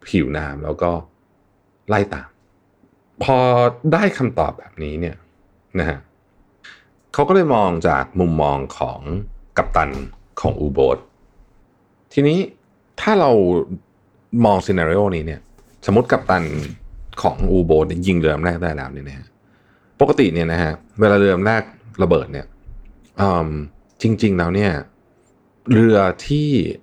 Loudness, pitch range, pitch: -18 LUFS, 85-105 Hz, 95 Hz